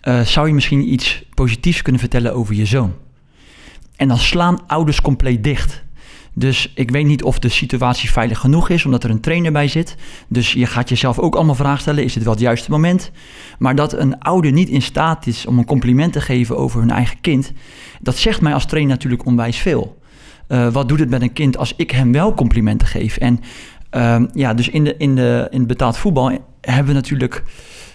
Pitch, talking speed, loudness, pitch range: 130 Hz, 215 wpm, -16 LUFS, 120-145 Hz